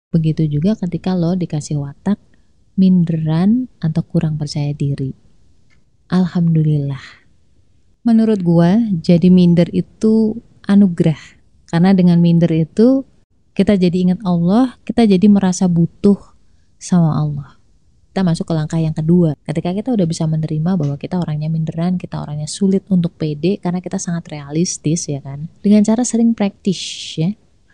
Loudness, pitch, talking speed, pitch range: -16 LUFS, 175 Hz, 135 wpm, 155-195 Hz